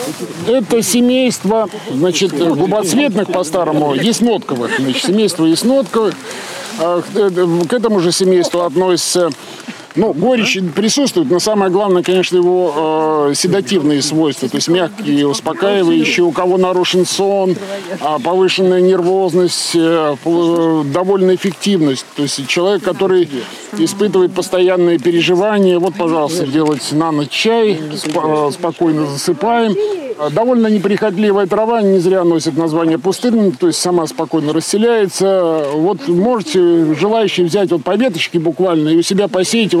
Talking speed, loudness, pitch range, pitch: 115 wpm, -13 LUFS, 165-200 Hz, 180 Hz